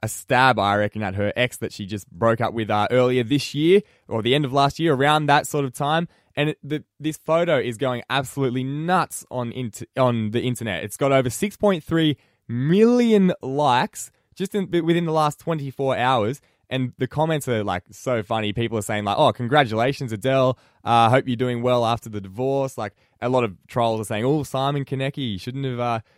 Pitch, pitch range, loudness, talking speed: 130 Hz, 115-145 Hz, -22 LUFS, 210 wpm